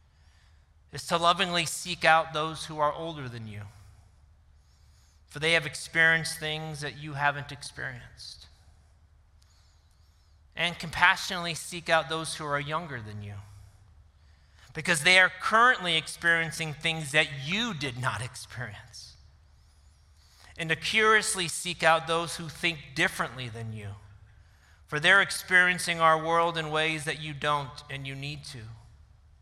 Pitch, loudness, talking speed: 145 Hz, -26 LUFS, 135 wpm